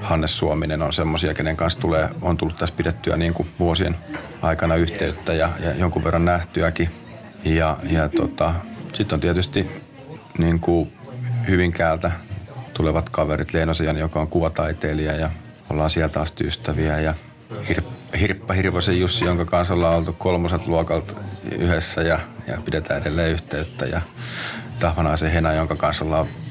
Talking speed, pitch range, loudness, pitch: 145 wpm, 80-90 Hz, -22 LUFS, 85 Hz